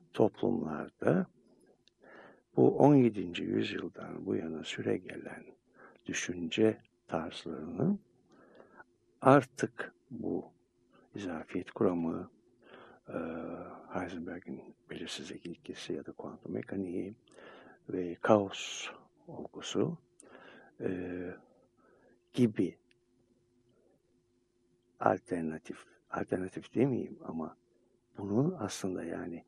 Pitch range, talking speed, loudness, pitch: 90-120 Hz, 65 wpm, -34 LUFS, 115 Hz